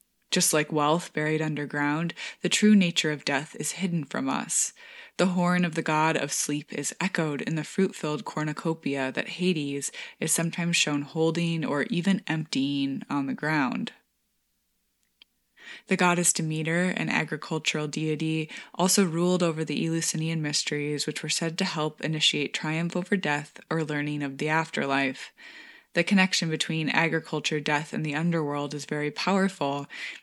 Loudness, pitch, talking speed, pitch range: -27 LUFS, 160 Hz, 155 wpm, 150-180 Hz